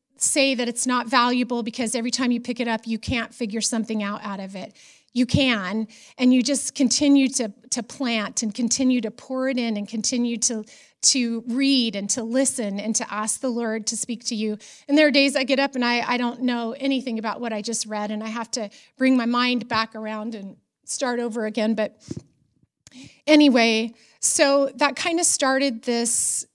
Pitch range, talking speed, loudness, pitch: 220-260 Hz, 205 wpm, -22 LUFS, 240 Hz